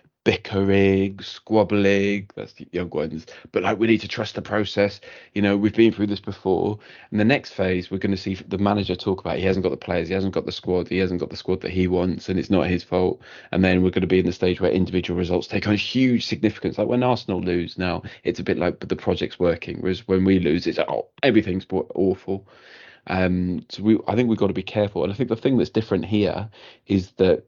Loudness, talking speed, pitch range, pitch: -22 LUFS, 250 wpm, 90-105 Hz, 95 Hz